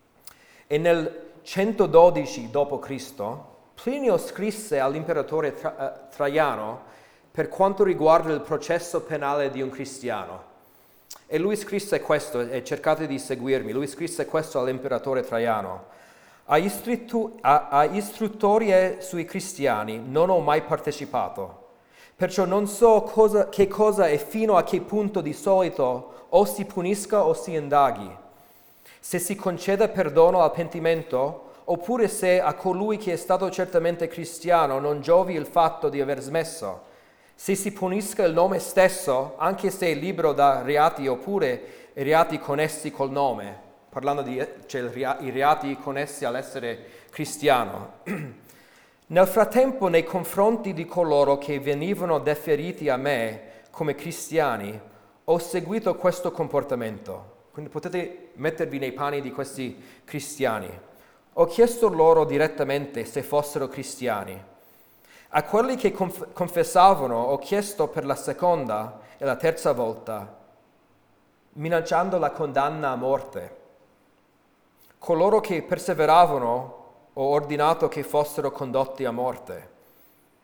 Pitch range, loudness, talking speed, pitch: 140-185 Hz, -24 LUFS, 125 wpm, 160 Hz